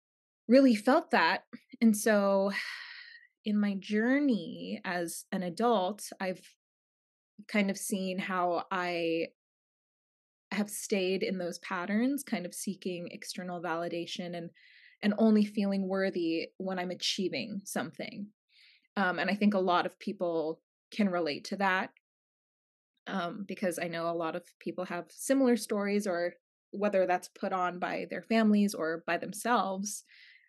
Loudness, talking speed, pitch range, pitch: -31 LUFS, 140 wpm, 175-220 Hz, 195 Hz